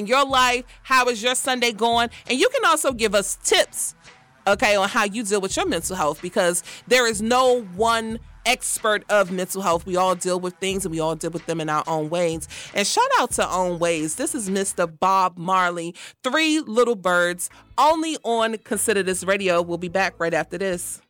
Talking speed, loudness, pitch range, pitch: 205 wpm, -21 LUFS, 175-240 Hz, 195 Hz